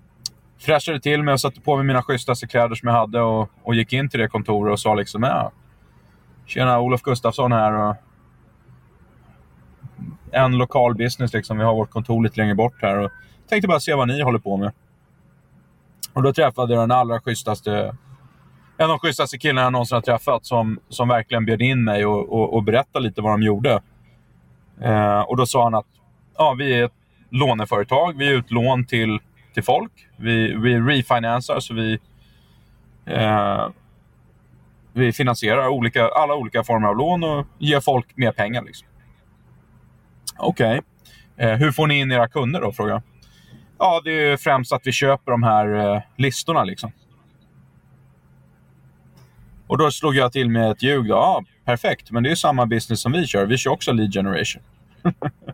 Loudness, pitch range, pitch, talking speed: -20 LUFS, 110-135 Hz, 120 Hz, 175 wpm